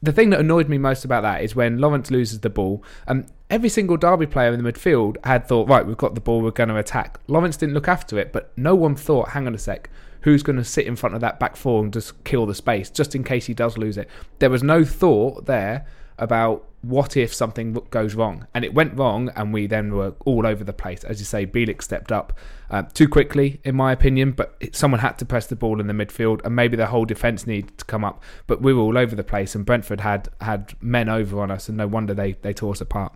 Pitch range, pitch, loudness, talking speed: 110-135 Hz, 120 Hz, -21 LUFS, 260 wpm